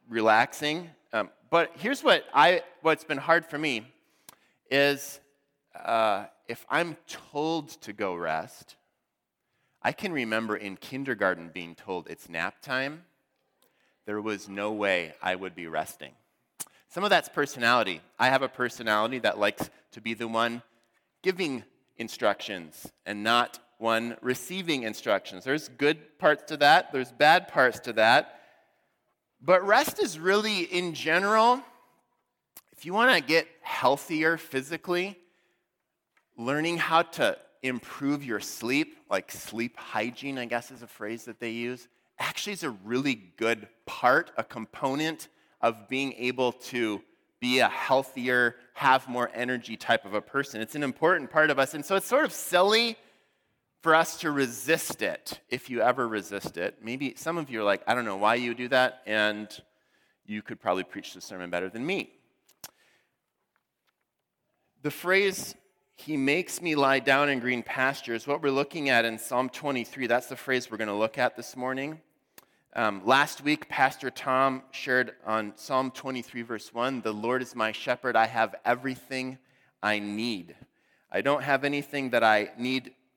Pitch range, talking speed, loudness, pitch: 115-150 Hz, 160 wpm, -27 LUFS, 130 Hz